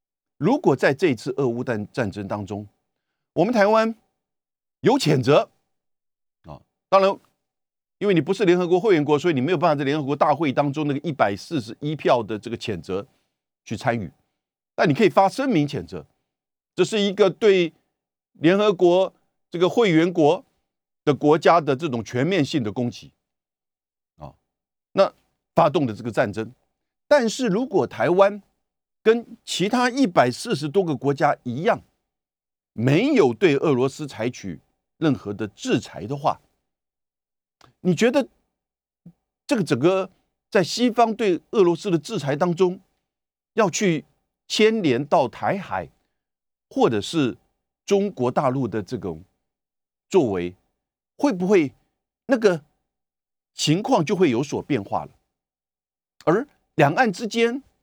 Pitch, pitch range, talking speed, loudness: 165 Hz, 130-200 Hz, 205 characters per minute, -22 LUFS